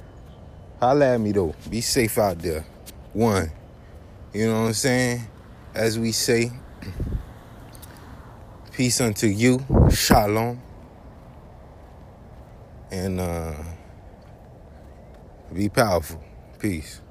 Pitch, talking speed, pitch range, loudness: 105 Hz, 90 wpm, 90-115 Hz, -23 LUFS